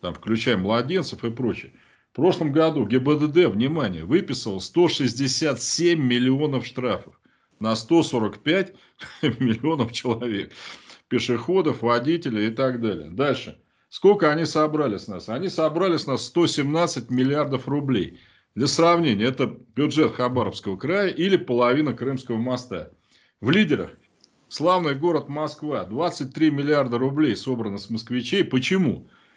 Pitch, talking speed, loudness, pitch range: 135 Hz, 120 wpm, -23 LUFS, 120-155 Hz